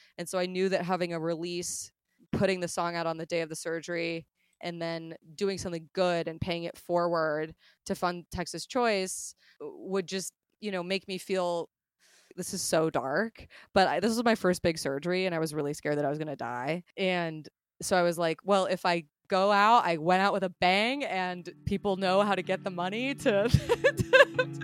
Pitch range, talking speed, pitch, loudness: 165-195 Hz, 210 wpm, 180 Hz, -29 LUFS